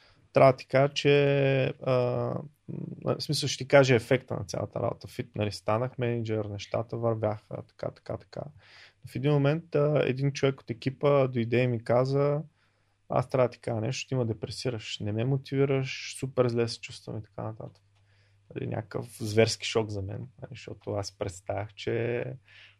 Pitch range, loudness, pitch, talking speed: 110-135 Hz, -28 LUFS, 120 Hz, 170 wpm